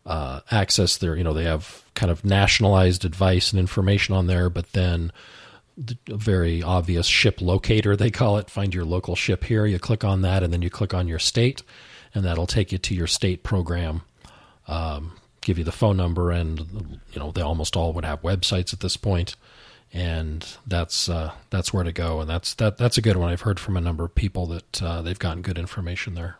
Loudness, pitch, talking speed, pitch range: -23 LUFS, 90 Hz, 215 wpm, 85-100 Hz